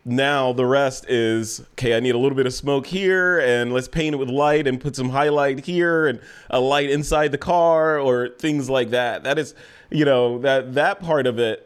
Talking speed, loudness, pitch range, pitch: 220 wpm, -20 LUFS, 125-150 Hz, 140 Hz